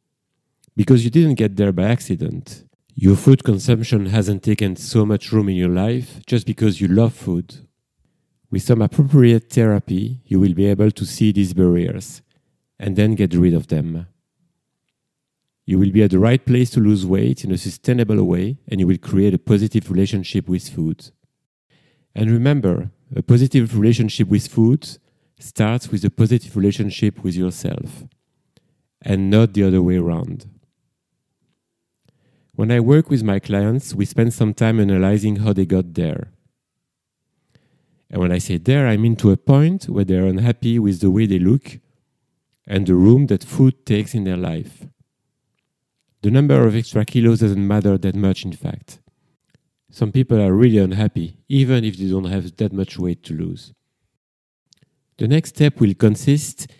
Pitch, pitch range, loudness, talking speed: 110 Hz, 95-130 Hz, -17 LUFS, 165 wpm